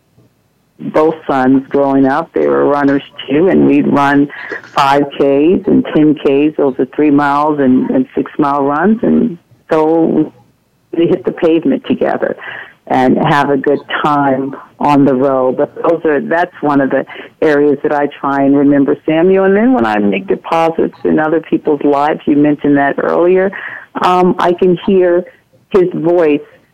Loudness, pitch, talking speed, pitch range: -12 LUFS, 145 Hz, 165 wpm, 140-165 Hz